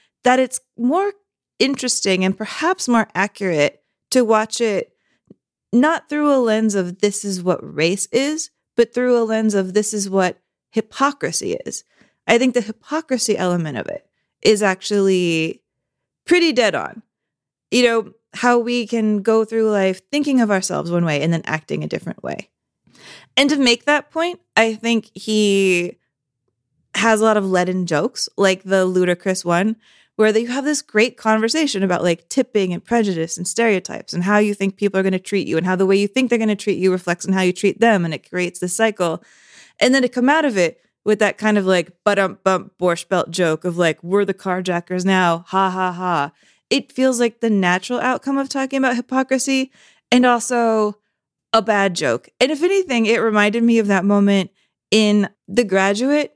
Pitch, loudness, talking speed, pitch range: 210 Hz, -18 LUFS, 185 wpm, 185-240 Hz